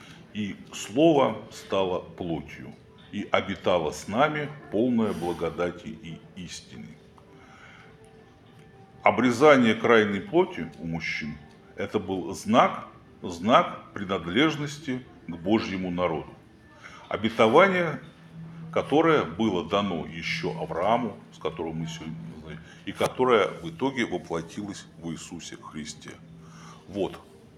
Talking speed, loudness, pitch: 100 wpm, -26 LUFS, 100 Hz